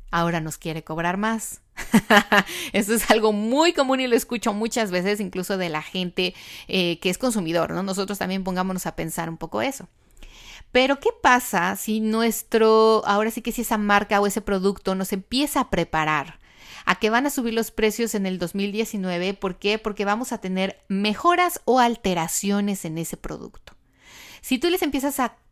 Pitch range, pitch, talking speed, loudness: 185-230 Hz, 205 Hz, 180 wpm, -22 LUFS